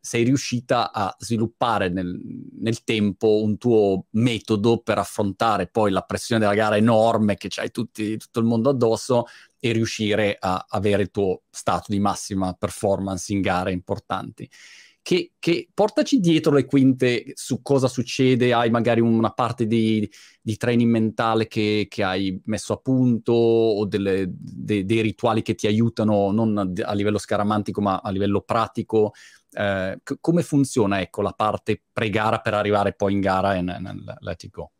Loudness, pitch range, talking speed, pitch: -22 LUFS, 100-115 Hz, 165 wpm, 110 Hz